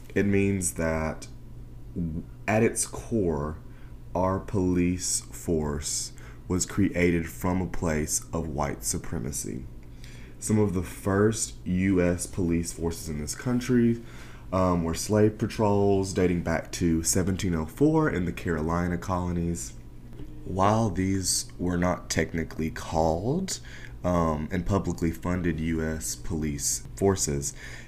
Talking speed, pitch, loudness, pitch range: 110 wpm, 90 Hz, -27 LUFS, 80-100 Hz